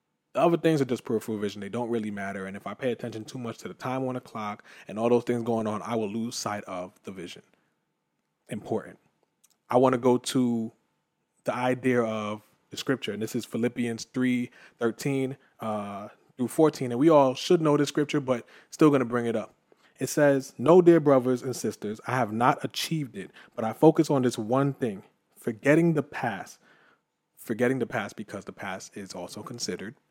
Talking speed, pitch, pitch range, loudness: 205 wpm, 125 Hz, 110-135 Hz, -27 LUFS